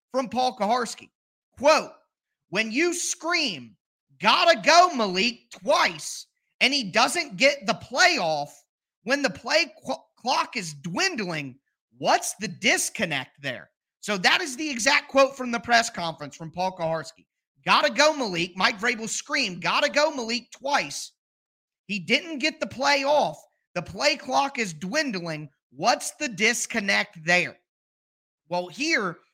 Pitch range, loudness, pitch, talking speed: 185-295 Hz, -23 LUFS, 240 Hz, 135 wpm